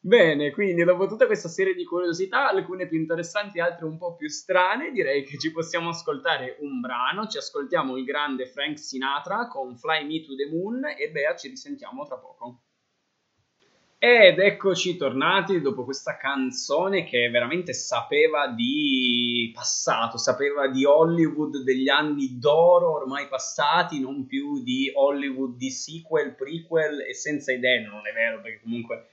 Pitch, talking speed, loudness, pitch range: 160 Hz, 155 wpm, -24 LUFS, 135-200 Hz